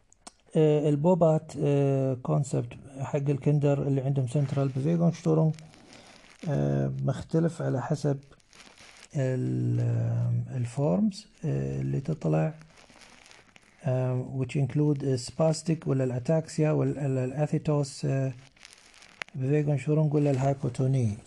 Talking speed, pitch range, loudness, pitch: 70 wpm, 130-150 Hz, -28 LUFS, 140 Hz